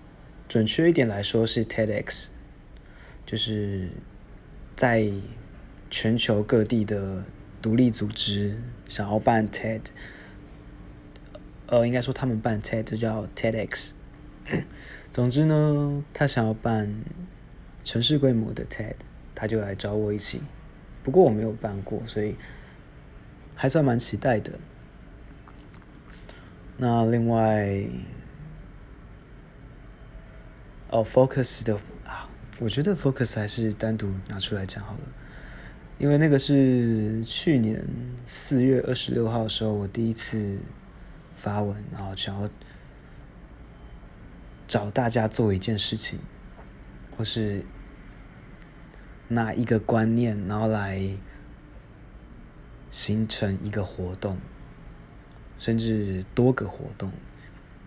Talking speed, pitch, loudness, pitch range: 175 characters per minute, 110 Hz, -26 LUFS, 105-120 Hz